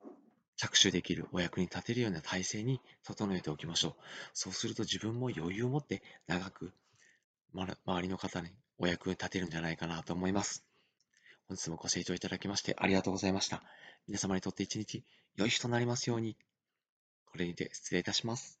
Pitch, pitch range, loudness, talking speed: 95 Hz, 90-110 Hz, -36 LUFS, 385 characters per minute